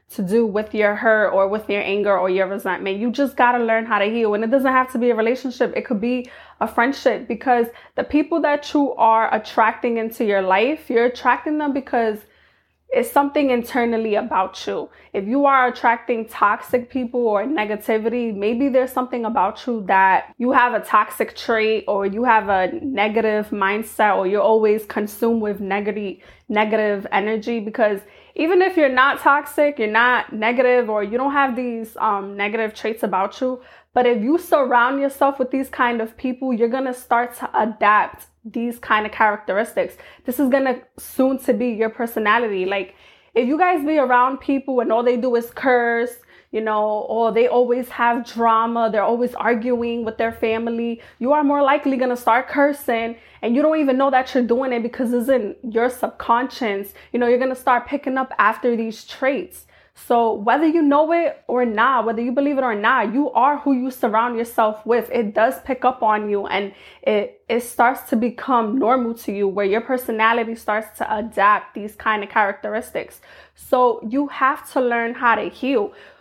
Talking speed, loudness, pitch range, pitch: 195 wpm, -19 LUFS, 220-260 Hz, 235 Hz